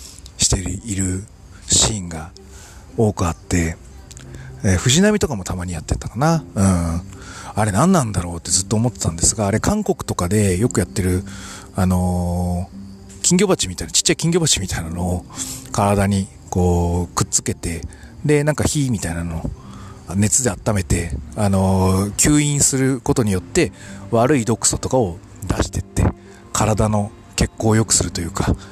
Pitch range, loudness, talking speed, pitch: 90-110 Hz, -19 LUFS, 325 characters per minute, 95 Hz